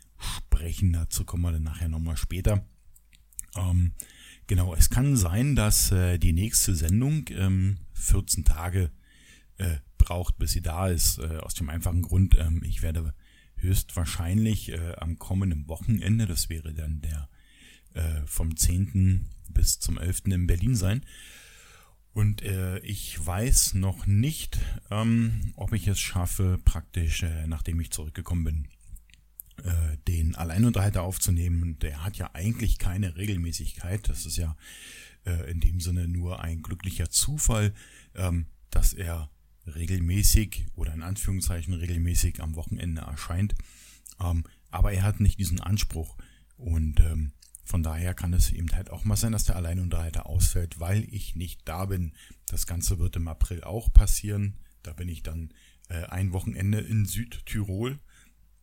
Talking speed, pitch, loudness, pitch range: 140 wpm, 90 Hz, -28 LUFS, 80-100 Hz